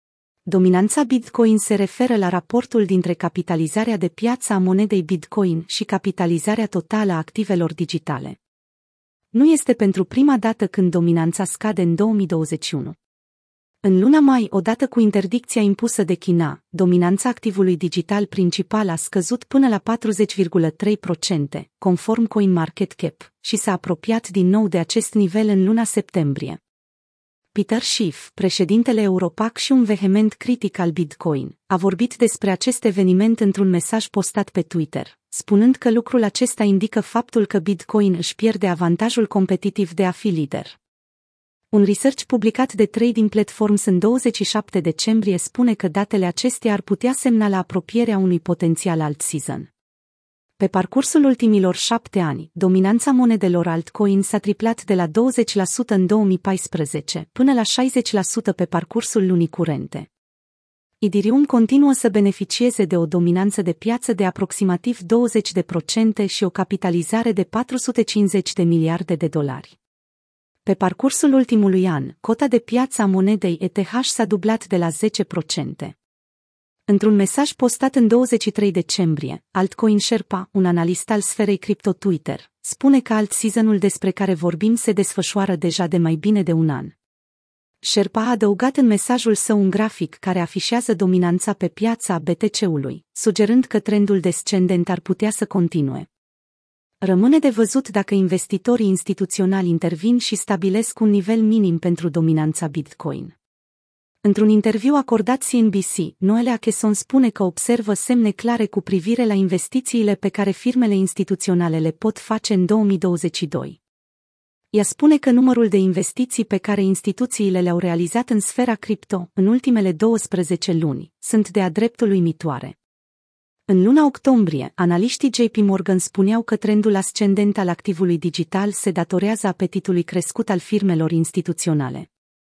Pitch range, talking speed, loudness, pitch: 180-225 Hz, 140 wpm, -19 LUFS, 200 Hz